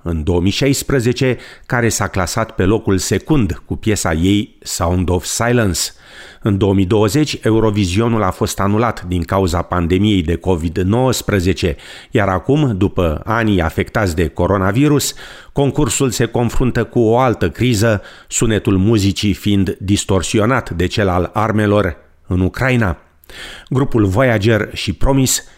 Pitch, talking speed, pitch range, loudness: 105 Hz, 125 wpm, 95-115 Hz, -16 LUFS